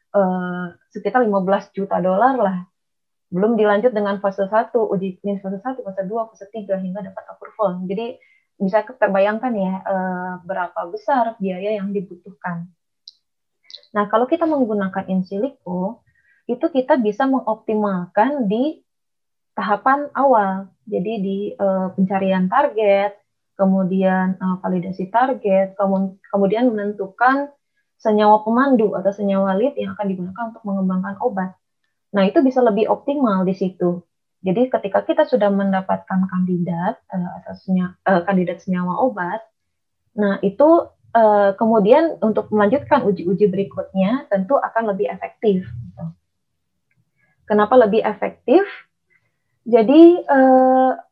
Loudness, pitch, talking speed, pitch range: -19 LUFS, 205 Hz, 115 wpm, 190-235 Hz